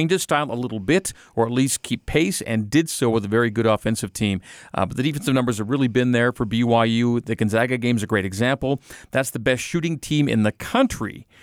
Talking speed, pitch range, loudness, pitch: 230 wpm, 110-135 Hz, -22 LUFS, 120 Hz